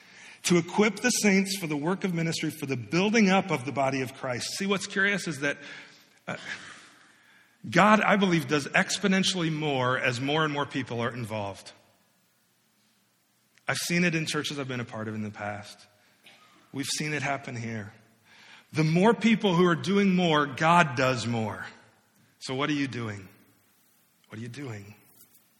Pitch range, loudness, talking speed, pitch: 115-175 Hz, -26 LUFS, 170 wpm, 145 Hz